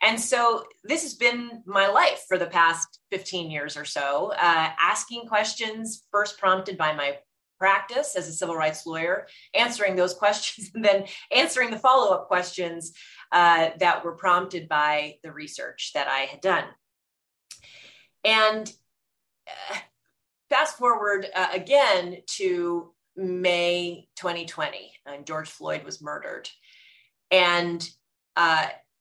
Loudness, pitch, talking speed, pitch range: -24 LUFS, 185 Hz, 130 wpm, 165-215 Hz